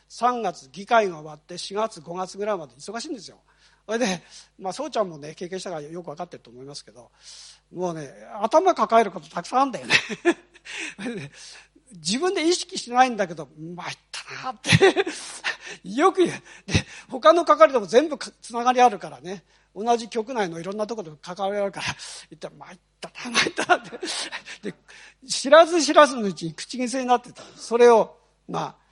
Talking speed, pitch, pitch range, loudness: 360 characters per minute, 215 Hz, 175-255 Hz, -22 LUFS